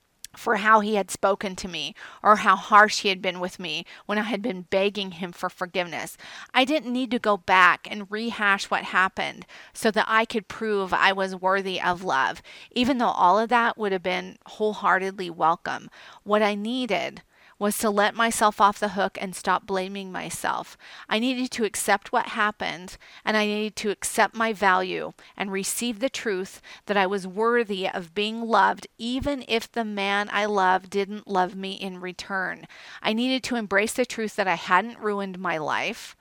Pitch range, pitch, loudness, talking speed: 190-220 Hz, 205 Hz, -24 LUFS, 190 wpm